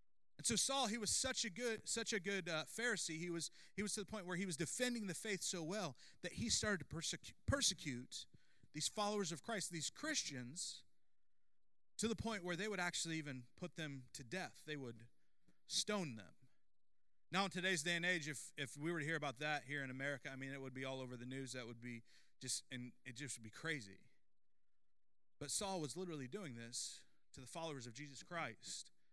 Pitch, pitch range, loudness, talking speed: 160 Hz, 135-195 Hz, -44 LUFS, 215 wpm